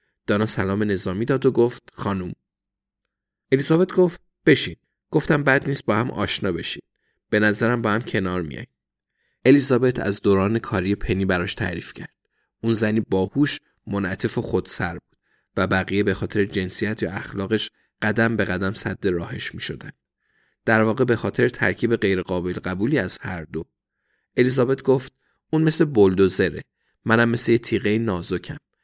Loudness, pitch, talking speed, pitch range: -22 LUFS, 110 Hz, 150 wpm, 95-125 Hz